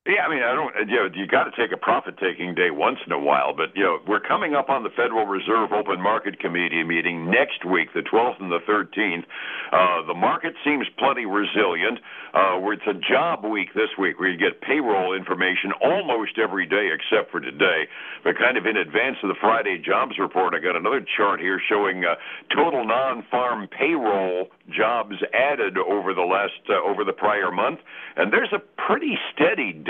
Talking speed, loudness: 200 wpm, -22 LUFS